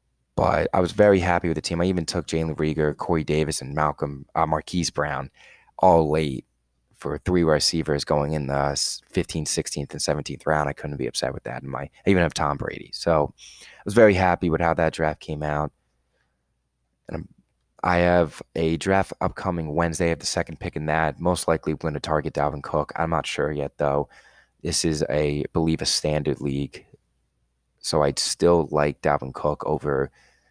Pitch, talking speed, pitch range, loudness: 75 Hz, 195 wpm, 70-85 Hz, -24 LUFS